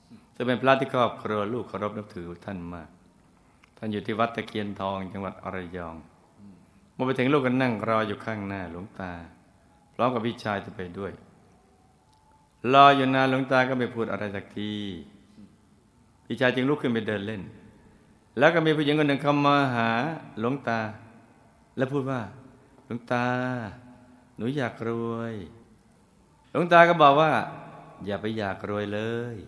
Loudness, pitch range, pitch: -25 LUFS, 100-130 Hz, 115 Hz